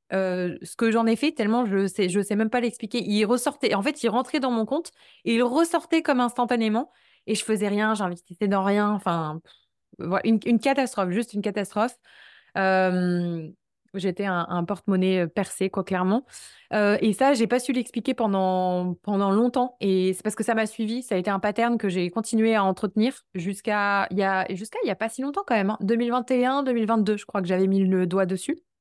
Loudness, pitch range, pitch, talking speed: -24 LUFS, 190-235 Hz, 210 Hz, 210 wpm